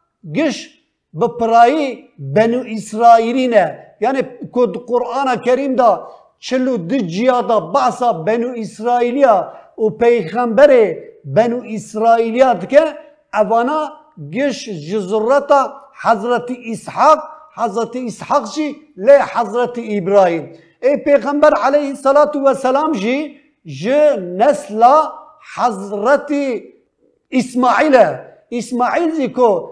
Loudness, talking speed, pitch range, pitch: -15 LUFS, 95 wpm, 230-285 Hz, 250 Hz